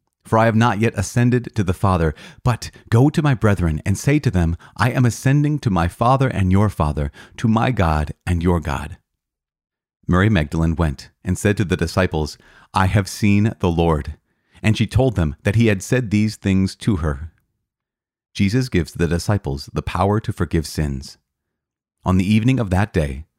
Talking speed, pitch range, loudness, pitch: 185 wpm, 80-115 Hz, -19 LUFS, 95 Hz